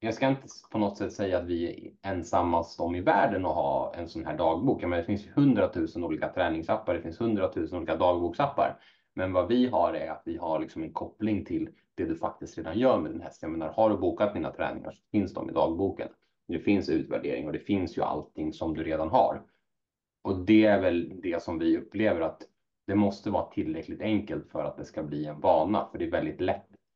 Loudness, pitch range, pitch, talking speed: -29 LUFS, 85-110 Hz, 100 Hz, 220 wpm